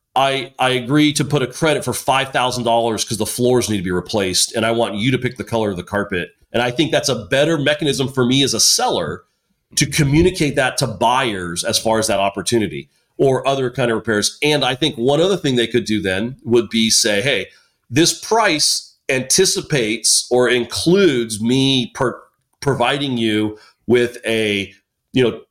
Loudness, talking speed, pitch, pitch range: -17 LUFS, 190 wpm, 120 Hz, 110-140 Hz